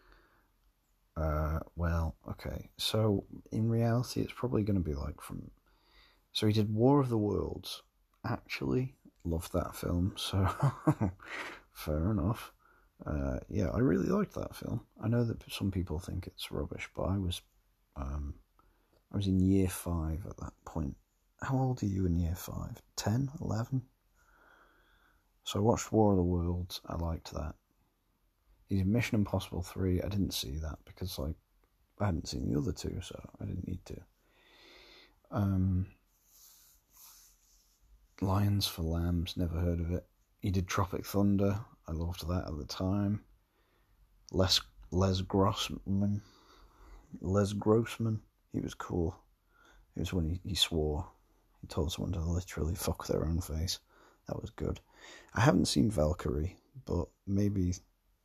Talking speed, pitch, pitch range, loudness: 150 wpm, 95 Hz, 85-100 Hz, -34 LUFS